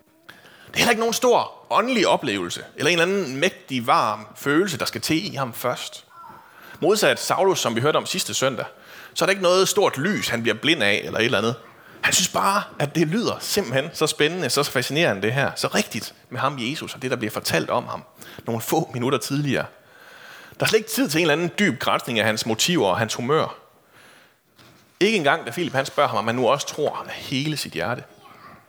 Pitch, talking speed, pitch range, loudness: 160 Hz, 220 wpm, 135-205 Hz, -22 LUFS